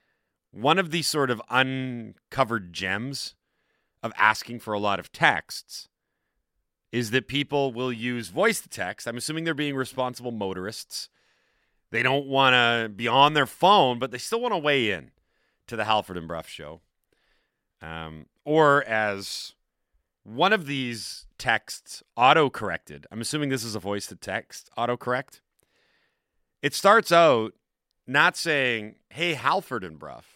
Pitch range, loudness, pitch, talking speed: 105-140 Hz, -24 LUFS, 120 Hz, 150 wpm